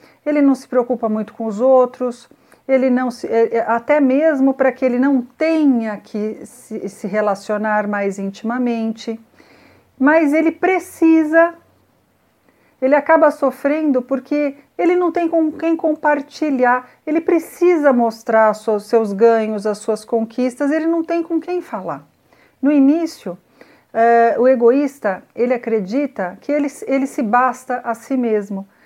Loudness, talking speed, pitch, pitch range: -17 LUFS, 130 wpm, 255 Hz, 225-295 Hz